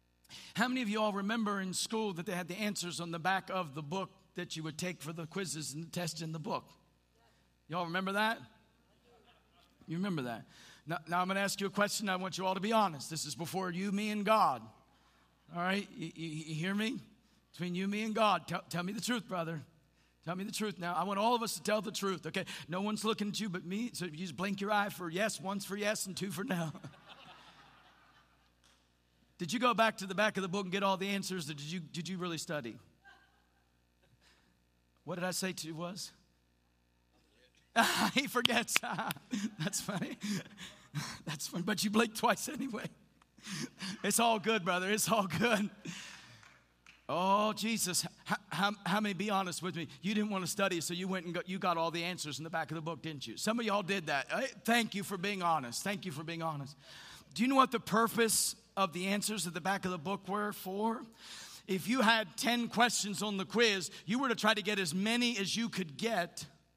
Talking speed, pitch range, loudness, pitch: 220 wpm, 170-210 Hz, -35 LUFS, 190 Hz